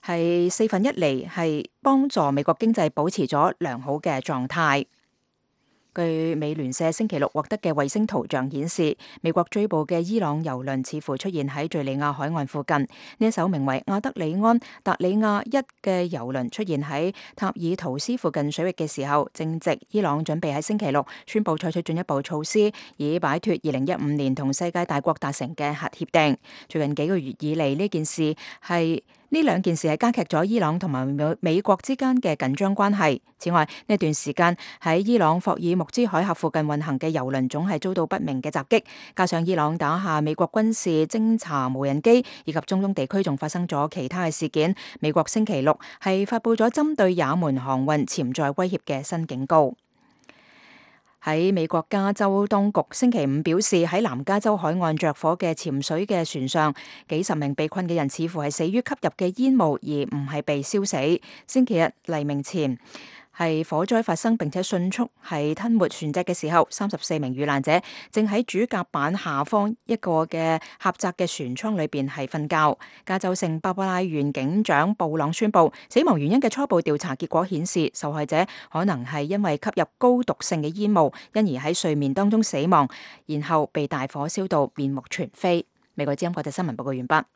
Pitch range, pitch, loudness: 150-195 Hz, 165 Hz, -24 LUFS